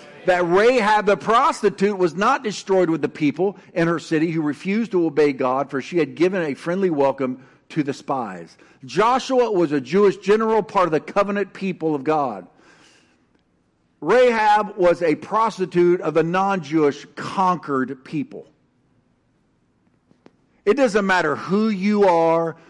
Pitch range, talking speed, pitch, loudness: 155-200 Hz, 150 wpm, 180 Hz, -20 LUFS